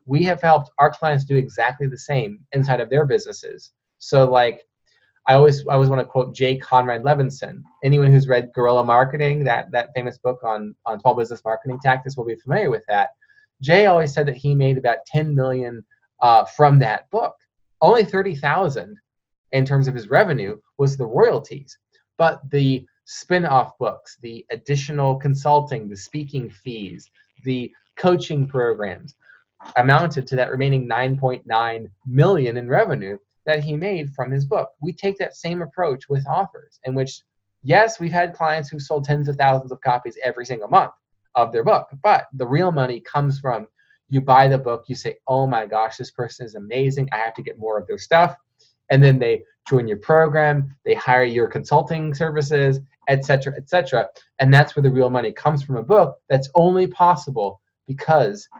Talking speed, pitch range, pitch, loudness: 185 wpm, 125-150 Hz, 135 Hz, -19 LUFS